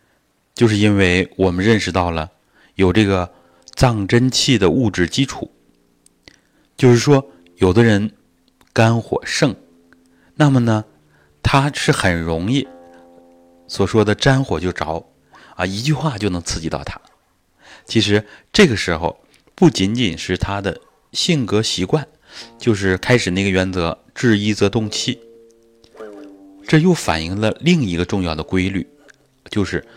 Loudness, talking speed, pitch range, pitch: -17 LUFS, 200 characters per minute, 90-120 Hz, 100 Hz